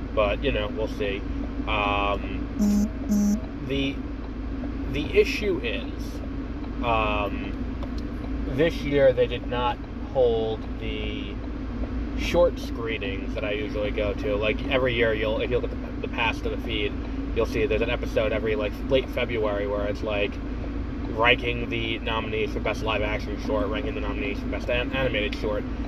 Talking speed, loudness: 155 wpm, -26 LUFS